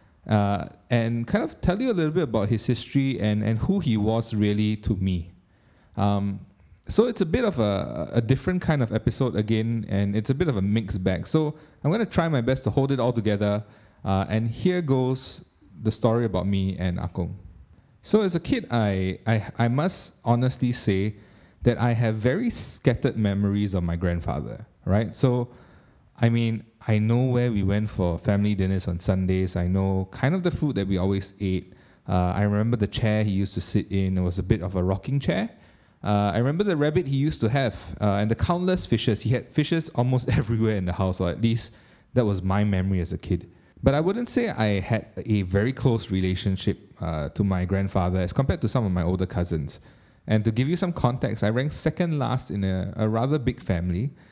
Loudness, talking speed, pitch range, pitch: -25 LUFS, 215 wpm, 95-125 Hz, 110 Hz